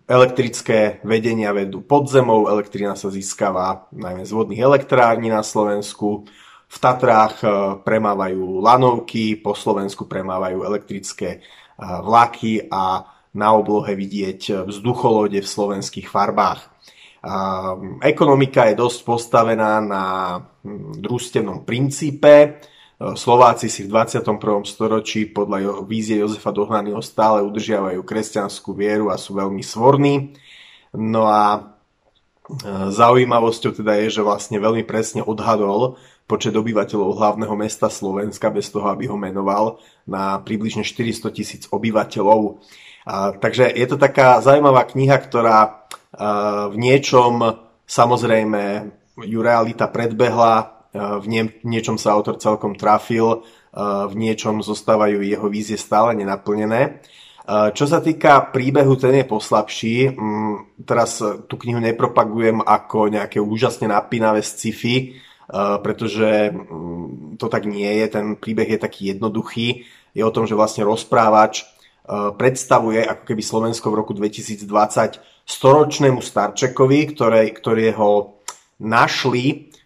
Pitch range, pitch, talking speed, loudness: 105-120 Hz, 110 Hz, 115 wpm, -18 LUFS